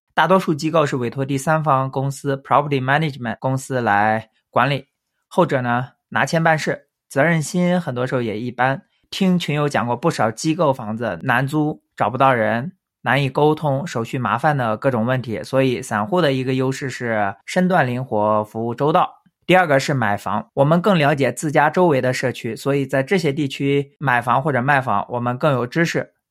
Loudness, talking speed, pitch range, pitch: -19 LUFS, 315 characters per minute, 120-155 Hz, 135 Hz